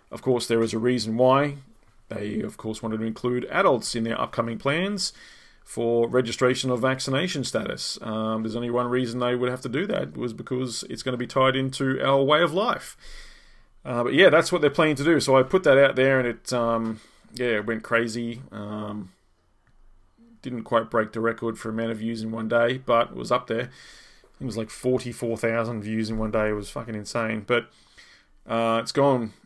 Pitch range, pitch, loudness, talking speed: 115-130 Hz, 120 Hz, -24 LUFS, 210 wpm